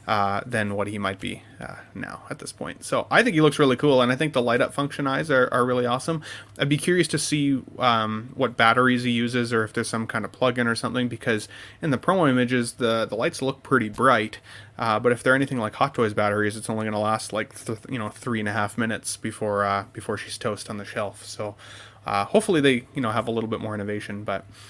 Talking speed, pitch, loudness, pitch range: 250 wpm, 115 Hz, -24 LUFS, 105-130 Hz